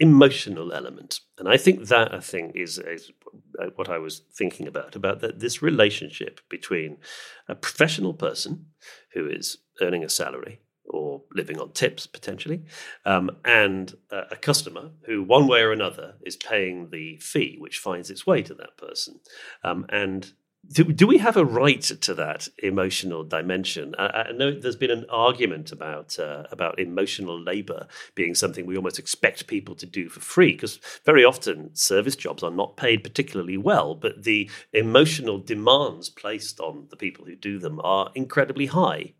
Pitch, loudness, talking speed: 150 Hz, -23 LUFS, 170 wpm